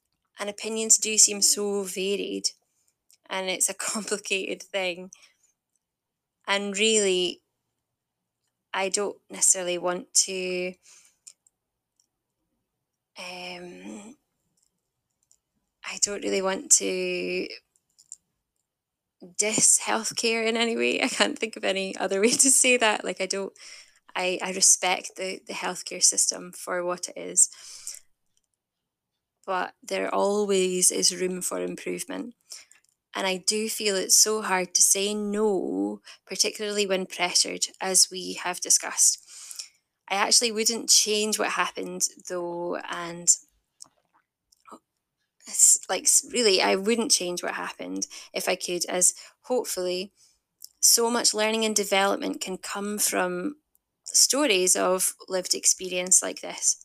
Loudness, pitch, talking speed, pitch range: -23 LUFS, 190 Hz, 115 wpm, 180-210 Hz